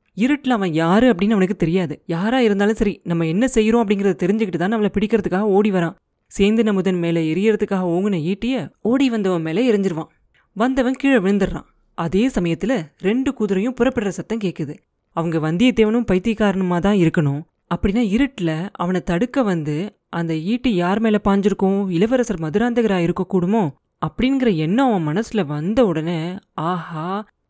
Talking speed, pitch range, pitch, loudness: 125 wpm, 175-225 Hz, 200 Hz, -19 LUFS